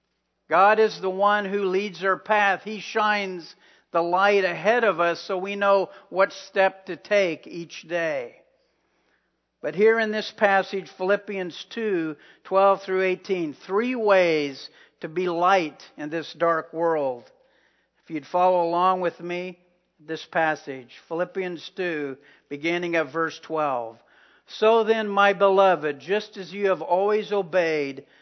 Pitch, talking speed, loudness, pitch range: 185 Hz, 140 wpm, -23 LUFS, 165-200 Hz